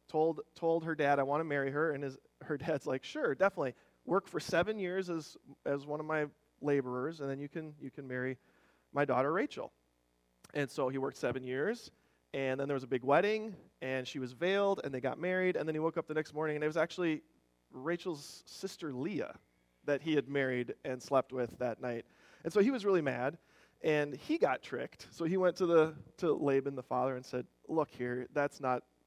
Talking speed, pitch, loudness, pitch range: 220 wpm, 145 Hz, -35 LUFS, 130-165 Hz